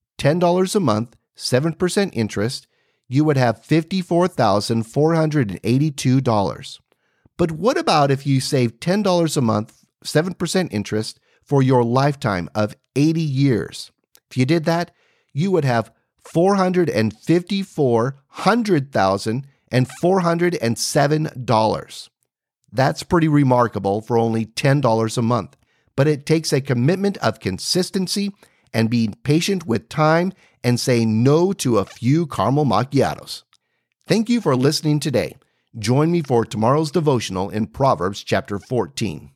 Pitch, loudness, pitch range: 140 Hz, -19 LUFS, 115-170 Hz